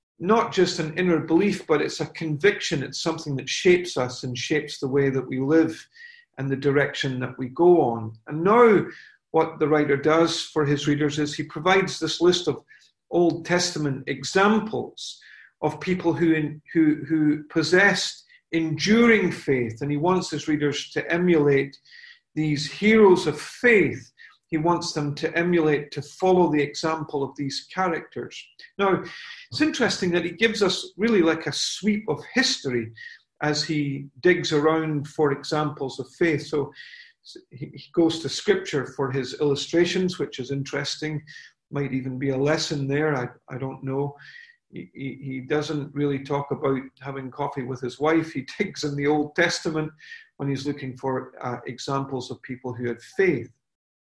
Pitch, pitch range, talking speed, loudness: 150 Hz, 140-175 Hz, 165 wpm, -23 LUFS